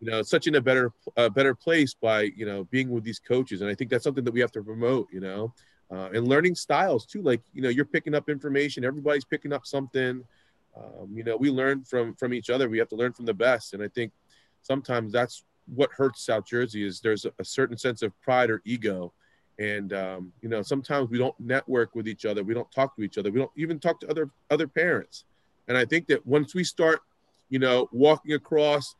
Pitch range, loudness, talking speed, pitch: 115-140 Hz, -26 LUFS, 240 wpm, 125 Hz